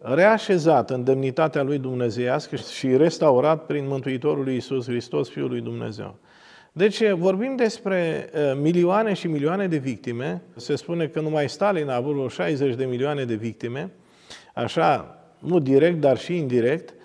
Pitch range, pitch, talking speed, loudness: 130-170 Hz, 145 Hz, 145 wpm, -23 LUFS